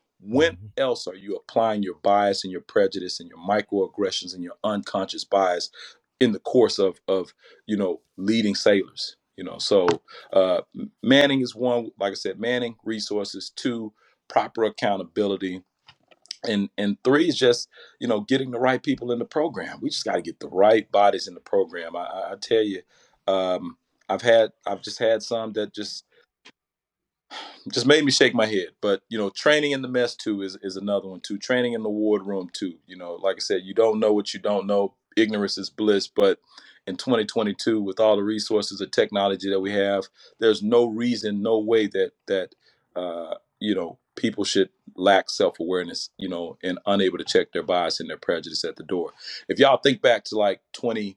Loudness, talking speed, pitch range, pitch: -24 LUFS, 195 wpm, 100-135 Hz, 110 Hz